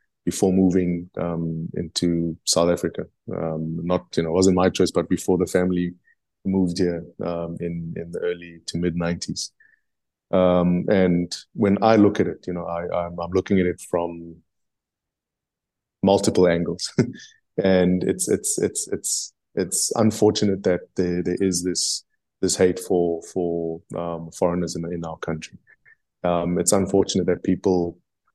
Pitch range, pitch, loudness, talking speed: 85-95 Hz, 90 Hz, -22 LUFS, 155 wpm